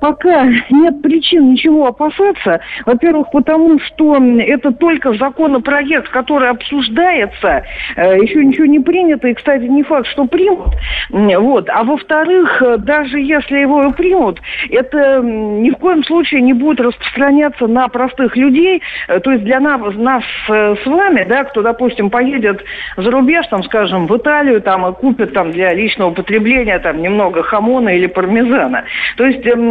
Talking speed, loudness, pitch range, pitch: 145 wpm, -11 LUFS, 230-300 Hz, 270 Hz